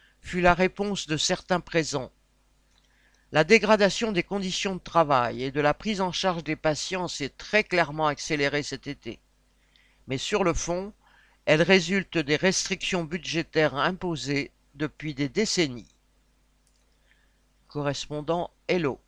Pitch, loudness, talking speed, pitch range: 165 Hz, -26 LUFS, 130 wpm, 145-185 Hz